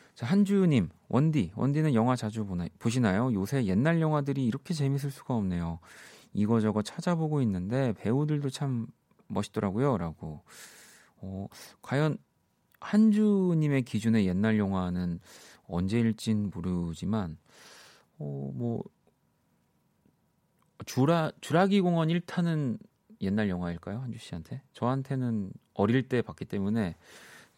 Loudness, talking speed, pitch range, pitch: -29 LUFS, 260 characters per minute, 100-145 Hz, 120 Hz